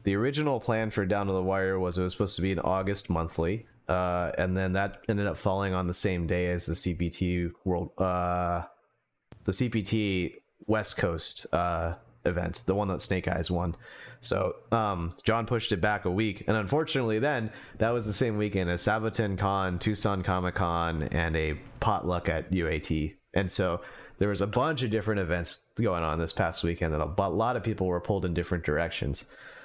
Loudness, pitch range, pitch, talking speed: -29 LUFS, 90-110 Hz, 95 Hz, 195 wpm